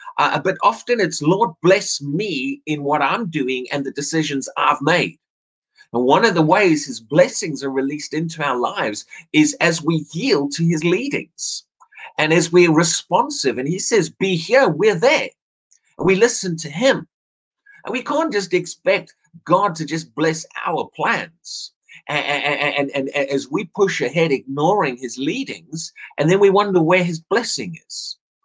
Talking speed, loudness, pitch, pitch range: 175 wpm, -18 LUFS, 165 Hz, 145-190 Hz